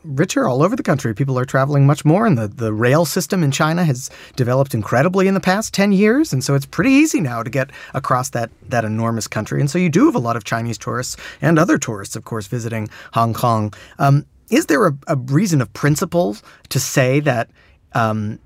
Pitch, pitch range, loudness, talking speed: 135 Hz, 115-160 Hz, -17 LUFS, 220 wpm